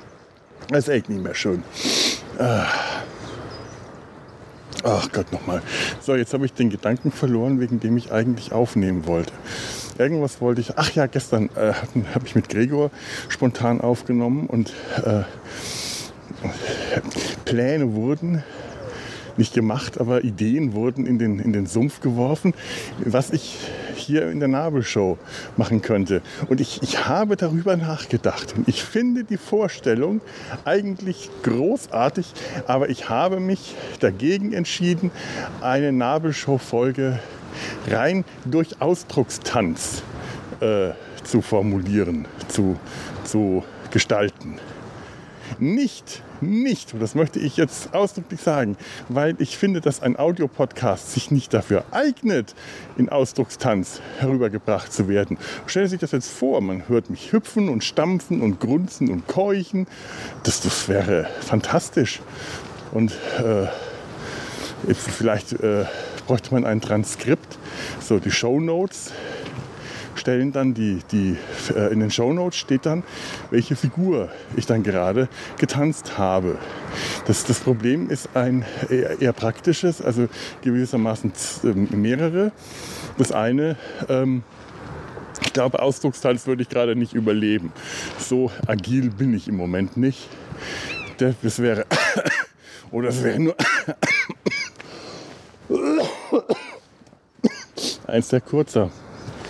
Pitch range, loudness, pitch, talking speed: 115-150 Hz, -22 LUFS, 125 Hz, 120 wpm